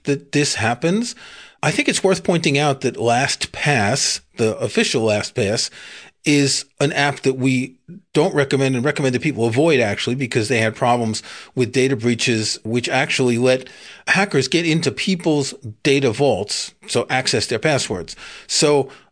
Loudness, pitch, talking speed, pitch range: -18 LUFS, 135 Hz, 150 wpm, 125-150 Hz